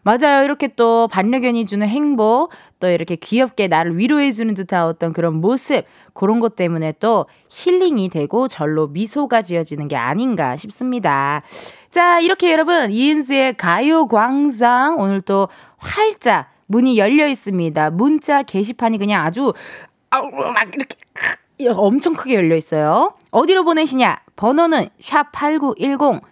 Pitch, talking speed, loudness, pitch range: 235 Hz, 295 characters per minute, -16 LUFS, 195-285 Hz